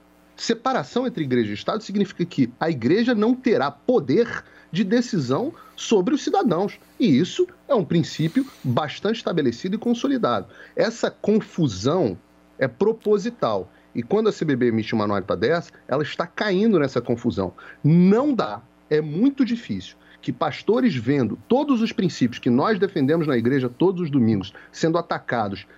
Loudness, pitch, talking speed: -22 LUFS, 180 Hz, 150 wpm